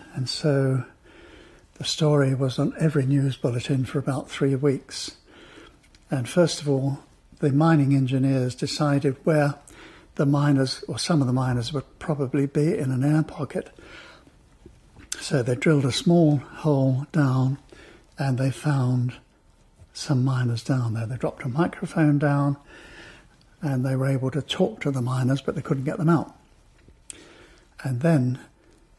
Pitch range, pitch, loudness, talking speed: 130-150 Hz, 140 Hz, -24 LUFS, 150 wpm